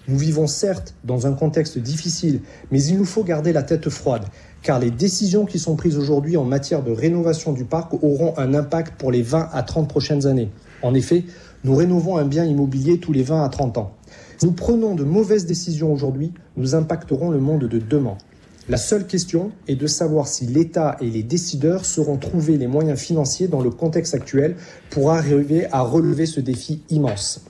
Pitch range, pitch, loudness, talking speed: 140-170 Hz, 155 Hz, -20 LUFS, 200 wpm